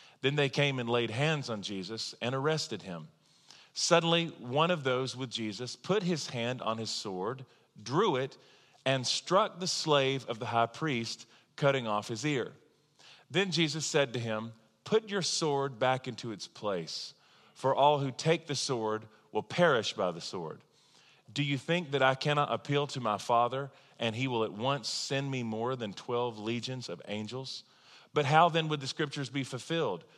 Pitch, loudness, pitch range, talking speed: 135 Hz, -31 LUFS, 115-150 Hz, 180 wpm